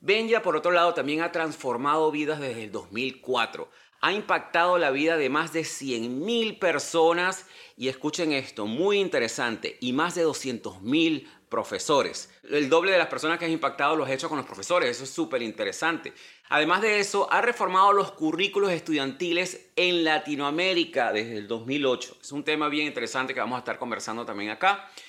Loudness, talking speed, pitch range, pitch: -26 LUFS, 175 wpm, 140-195 Hz, 165 Hz